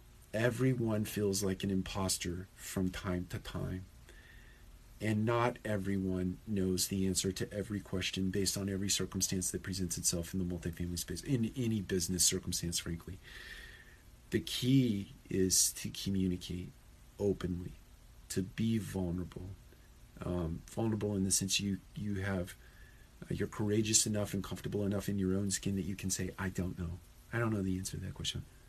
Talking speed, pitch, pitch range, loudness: 160 wpm, 95 Hz, 90-100 Hz, -35 LUFS